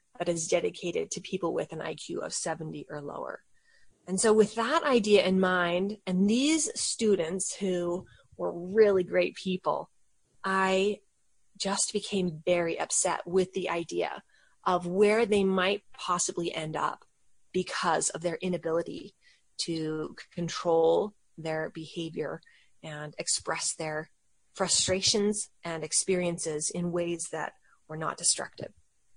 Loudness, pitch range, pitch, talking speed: -29 LUFS, 170-200 Hz, 185 Hz, 130 wpm